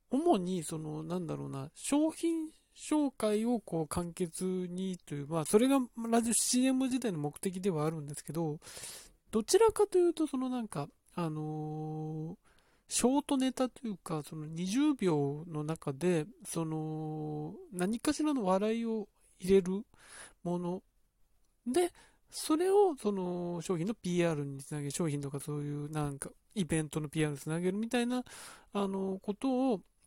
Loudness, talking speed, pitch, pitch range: -34 LUFS, 280 characters per minute, 185 Hz, 155-245 Hz